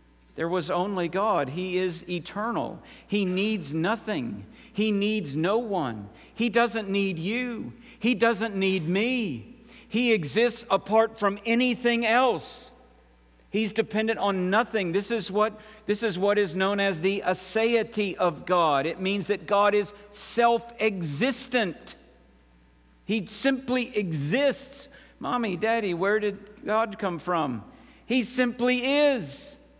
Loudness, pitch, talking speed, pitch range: -26 LUFS, 210 Hz, 130 wpm, 185-230 Hz